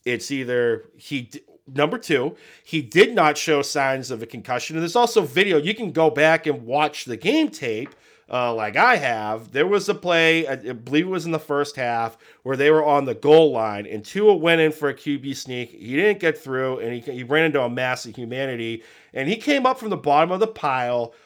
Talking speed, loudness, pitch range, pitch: 225 wpm, -21 LUFS, 125-160 Hz, 145 Hz